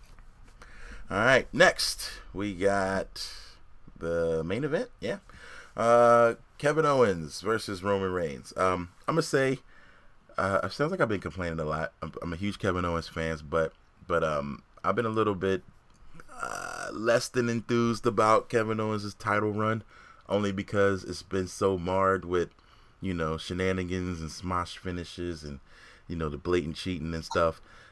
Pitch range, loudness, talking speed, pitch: 85-105 Hz, -29 LUFS, 155 wpm, 95 Hz